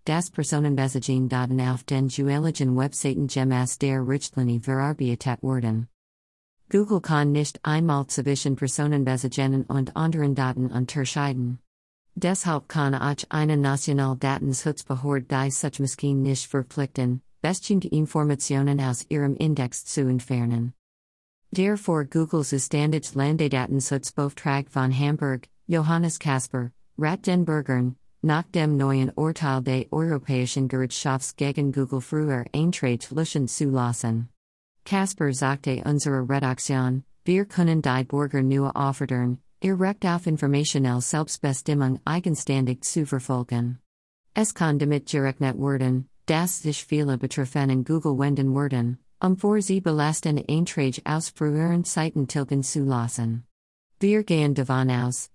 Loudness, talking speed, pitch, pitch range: -25 LUFS, 120 wpm, 140 Hz, 130-155 Hz